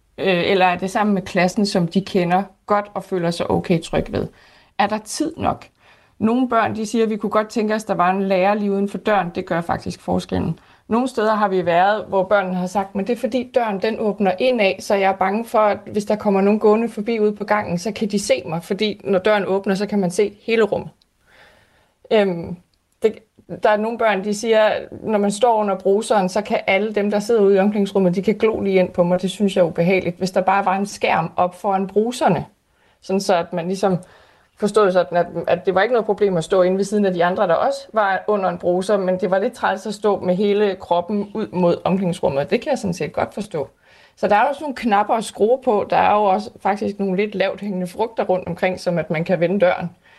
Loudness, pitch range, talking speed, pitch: -19 LUFS, 185-215 Hz, 245 wpm, 200 Hz